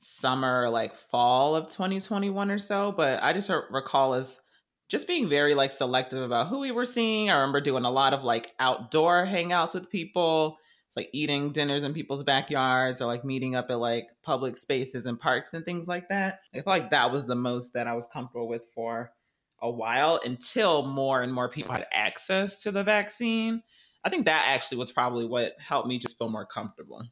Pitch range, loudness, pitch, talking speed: 125-175 Hz, -27 LUFS, 135 Hz, 210 wpm